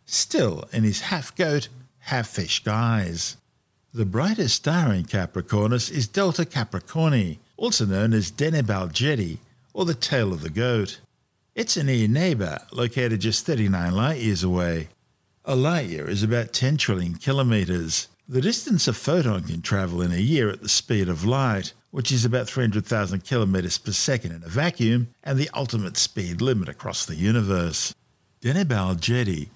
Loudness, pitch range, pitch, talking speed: -24 LUFS, 95-135 Hz, 115 Hz, 150 wpm